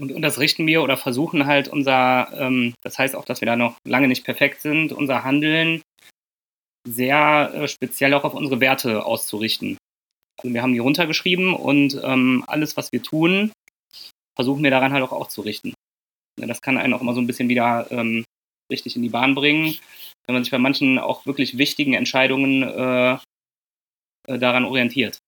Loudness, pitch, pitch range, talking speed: -19 LUFS, 130 Hz, 125-145 Hz, 165 wpm